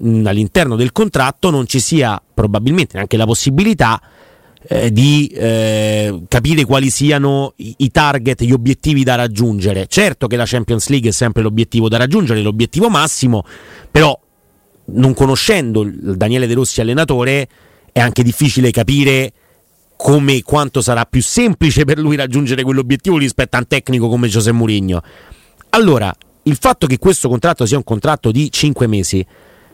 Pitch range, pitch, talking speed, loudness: 115-140 Hz, 125 Hz, 150 wpm, -13 LUFS